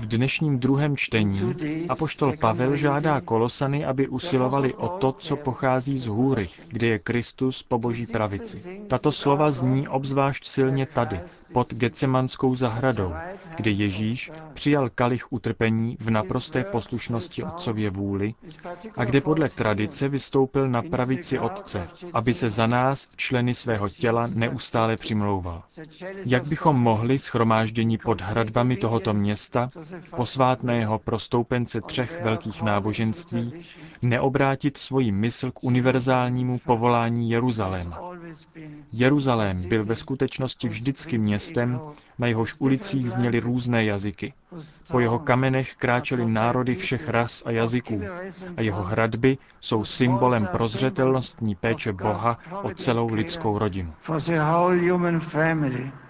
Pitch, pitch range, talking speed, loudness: 125 Hz, 115-135 Hz, 120 wpm, -24 LUFS